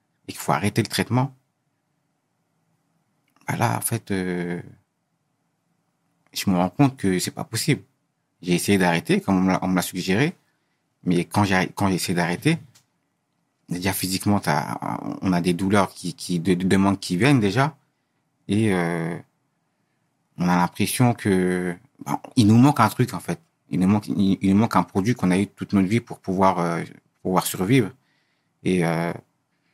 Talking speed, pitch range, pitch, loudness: 160 wpm, 90-140 Hz, 100 Hz, -22 LUFS